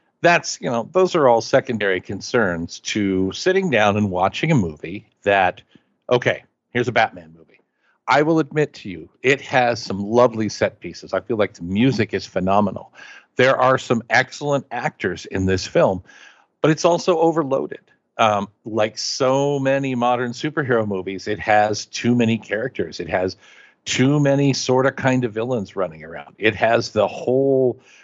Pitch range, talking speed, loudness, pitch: 105-135 Hz, 165 wpm, -20 LUFS, 125 Hz